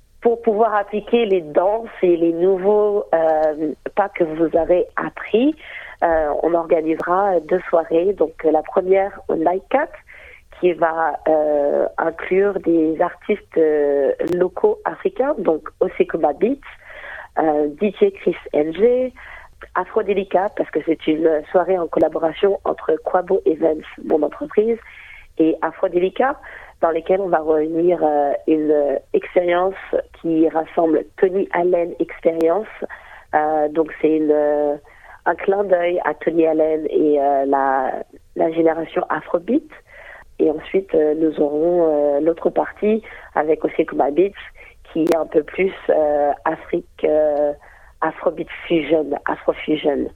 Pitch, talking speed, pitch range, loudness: 170 Hz, 130 wpm, 155-200 Hz, -19 LUFS